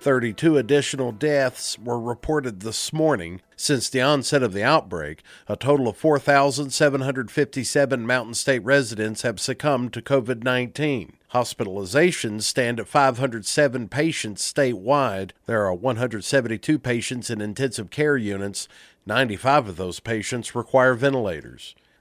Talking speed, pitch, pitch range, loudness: 125 wpm, 130 Hz, 115-140 Hz, -22 LUFS